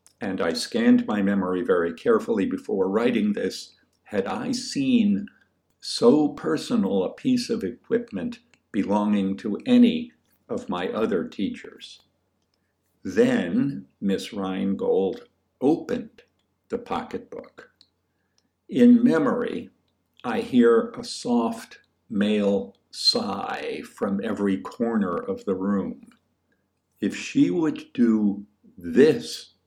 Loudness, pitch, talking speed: -24 LUFS, 235 Hz, 105 wpm